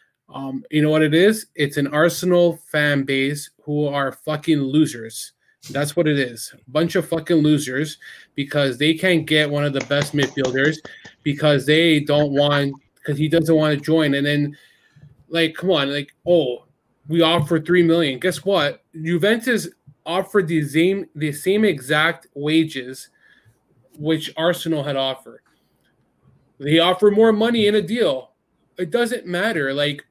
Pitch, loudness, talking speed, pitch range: 155 Hz, -19 LUFS, 155 wpm, 145-170 Hz